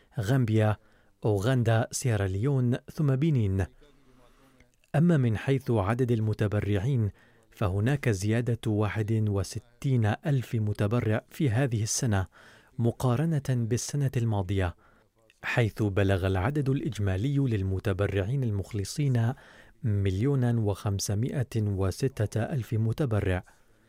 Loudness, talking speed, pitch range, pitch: -28 LUFS, 85 wpm, 105-130 Hz, 115 Hz